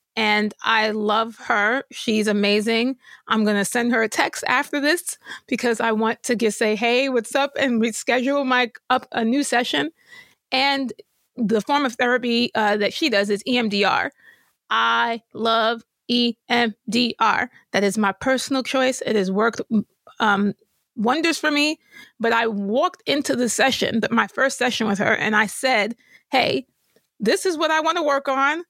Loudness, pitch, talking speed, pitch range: -21 LUFS, 235 Hz, 165 wpm, 220-270 Hz